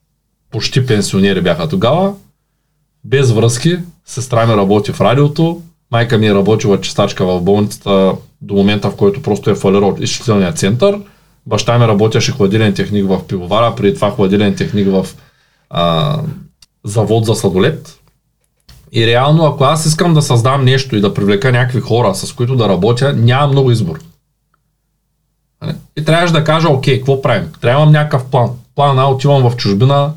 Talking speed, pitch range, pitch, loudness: 155 wpm, 105-150 Hz, 130 Hz, -12 LUFS